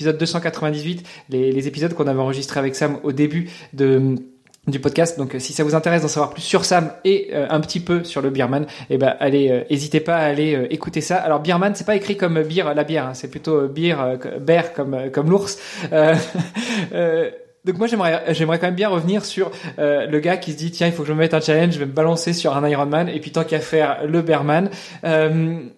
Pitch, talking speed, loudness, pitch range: 160 Hz, 240 wpm, -19 LUFS, 145-170 Hz